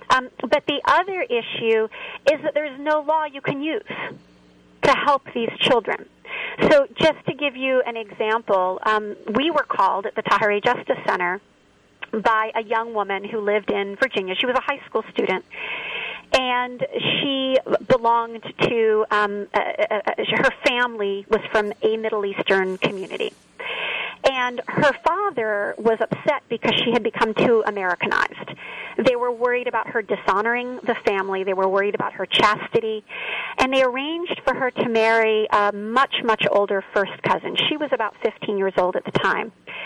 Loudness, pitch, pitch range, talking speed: -21 LUFS, 235 Hz, 210-290 Hz, 165 wpm